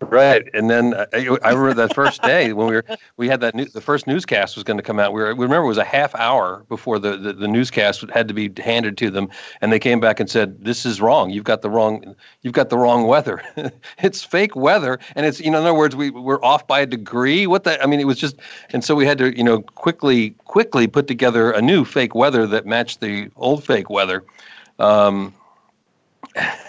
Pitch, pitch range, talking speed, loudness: 120 Hz, 110-140 Hz, 240 wpm, -17 LUFS